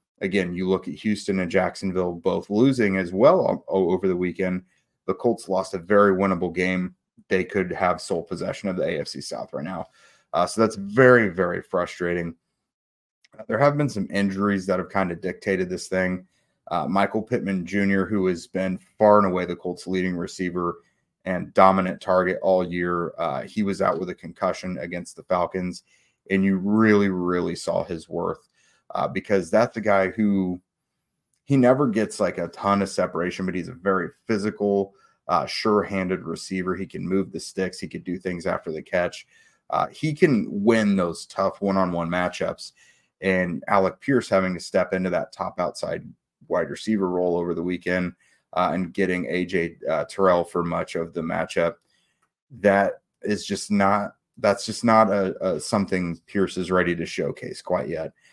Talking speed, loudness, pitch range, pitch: 175 wpm, -24 LUFS, 90-100 Hz, 95 Hz